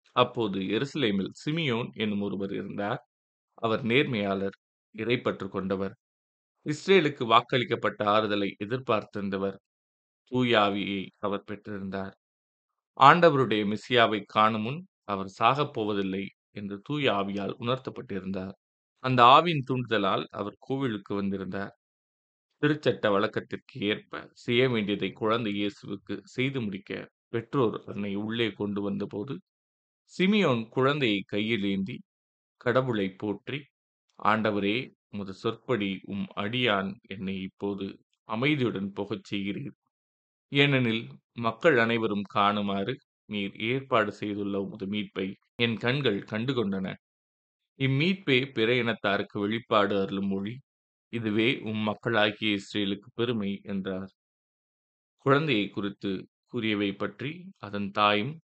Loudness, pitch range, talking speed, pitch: -28 LUFS, 100-120 Hz, 95 wpm, 105 Hz